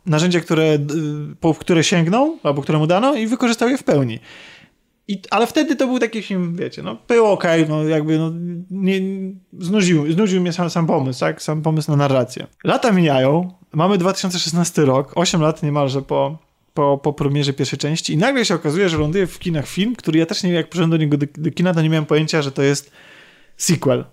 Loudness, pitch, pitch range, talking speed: -18 LUFS, 165 Hz, 150-190 Hz, 200 wpm